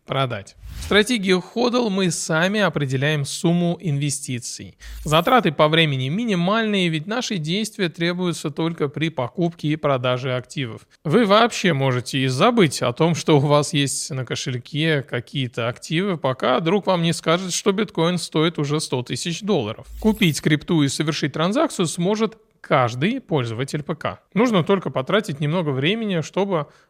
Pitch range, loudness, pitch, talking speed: 145-190 Hz, -21 LUFS, 160 Hz, 145 wpm